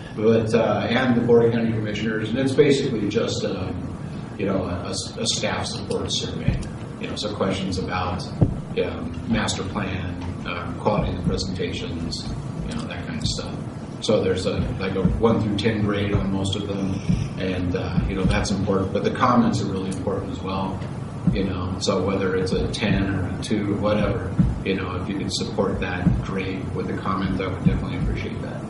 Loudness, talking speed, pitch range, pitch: -24 LUFS, 200 wpm, 95-110 Hz, 100 Hz